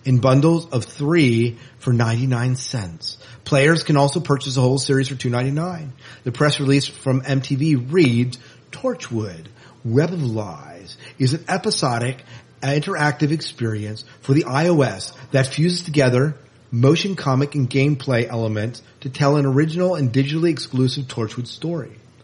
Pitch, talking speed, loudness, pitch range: 135 Hz, 140 wpm, -20 LUFS, 120-150 Hz